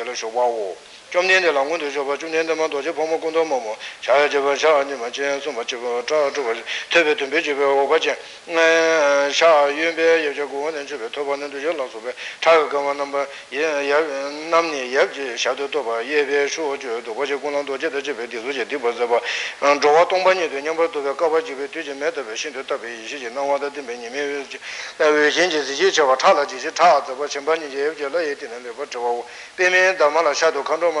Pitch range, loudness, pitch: 140-165 Hz, -20 LUFS, 145 Hz